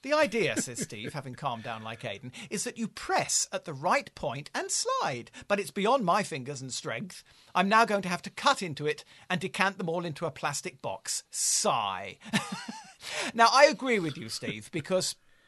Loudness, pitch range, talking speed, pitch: -29 LUFS, 150-225 Hz, 200 wpm, 185 Hz